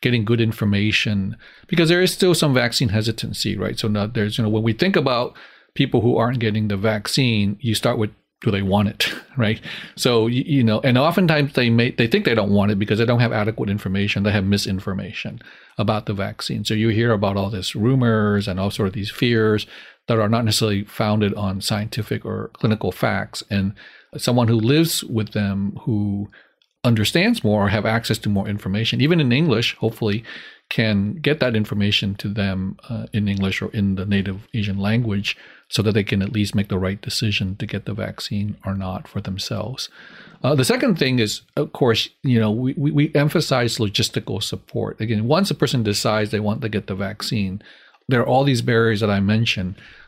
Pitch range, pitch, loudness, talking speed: 100-120 Hz, 110 Hz, -20 LUFS, 200 wpm